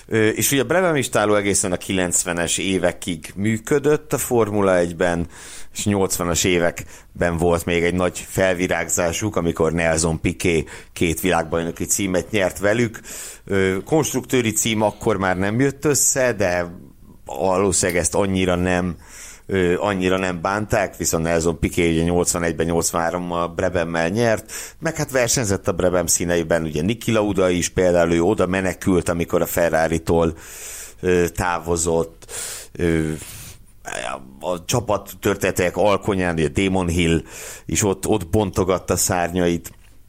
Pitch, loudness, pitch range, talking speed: 90 Hz, -20 LUFS, 85-105 Hz, 120 wpm